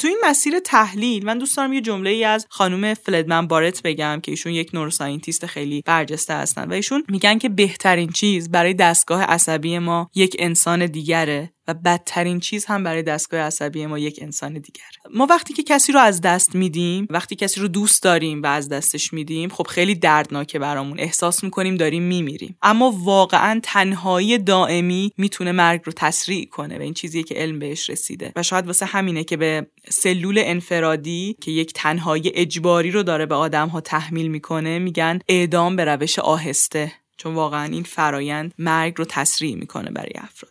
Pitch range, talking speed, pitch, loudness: 160-195 Hz, 180 wpm, 170 Hz, -19 LUFS